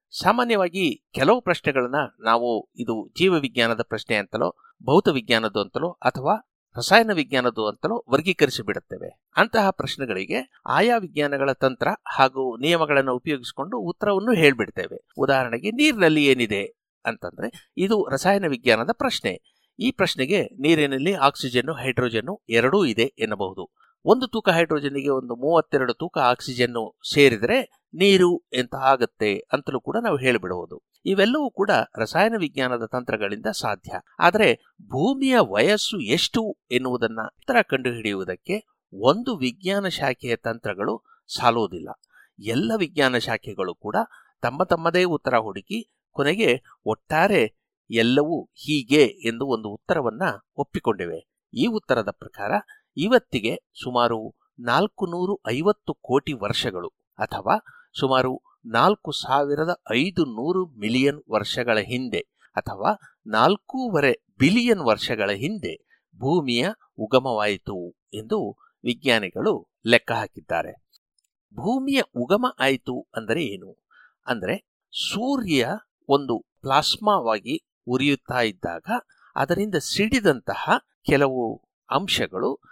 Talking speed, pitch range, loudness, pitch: 100 wpm, 125-205 Hz, -23 LUFS, 150 Hz